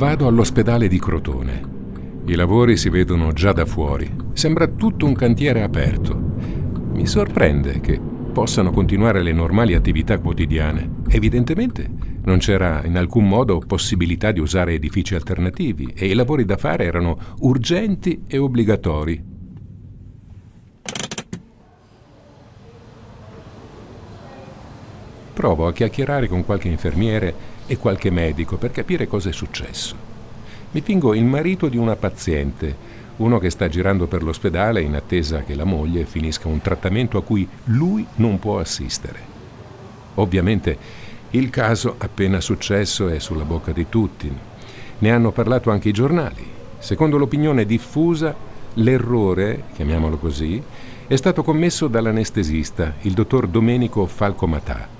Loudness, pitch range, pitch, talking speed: -19 LUFS, 90-120 Hz, 105 Hz, 125 wpm